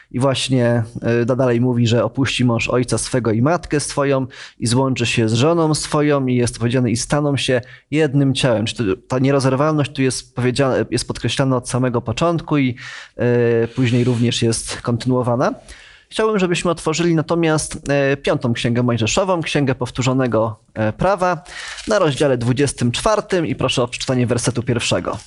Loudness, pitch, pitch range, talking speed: -18 LUFS, 130 Hz, 120-145 Hz, 145 wpm